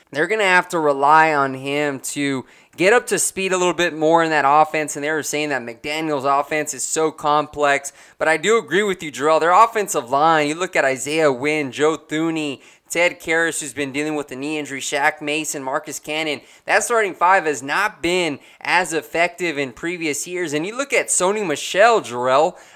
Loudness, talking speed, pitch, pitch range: -19 LUFS, 205 wpm, 155 Hz, 145-170 Hz